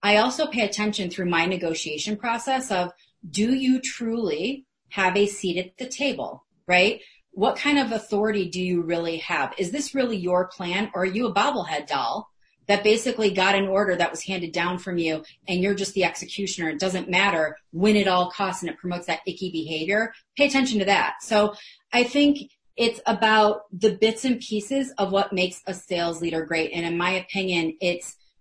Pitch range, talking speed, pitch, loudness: 180-220 Hz, 195 wpm, 195 Hz, -24 LUFS